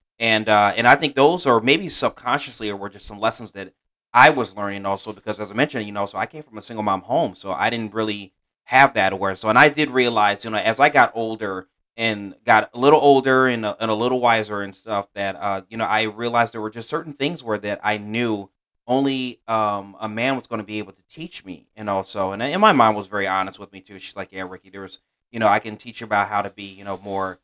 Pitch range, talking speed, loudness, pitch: 100-115 Hz, 265 wpm, -20 LUFS, 105 Hz